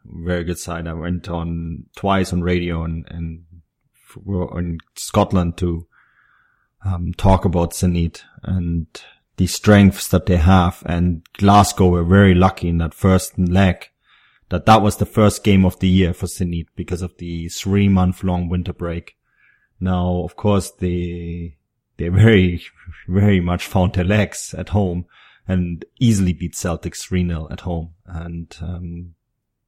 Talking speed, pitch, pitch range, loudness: 150 wpm, 90 Hz, 85-95 Hz, -18 LUFS